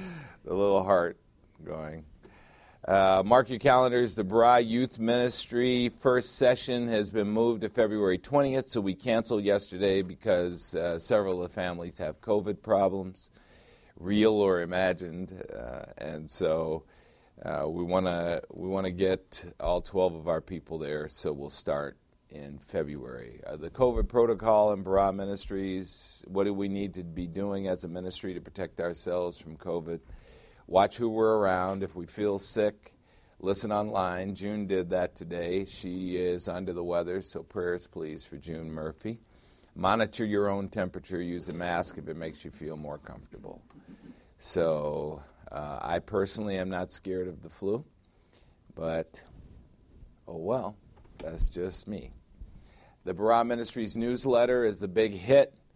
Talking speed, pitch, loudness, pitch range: 150 wpm, 95 Hz, -29 LUFS, 90-110 Hz